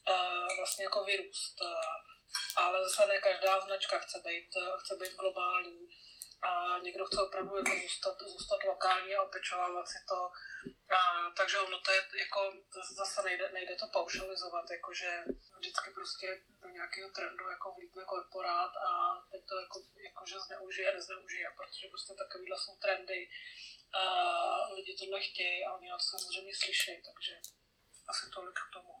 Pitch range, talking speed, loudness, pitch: 185-210 Hz, 155 wpm, -36 LUFS, 190 Hz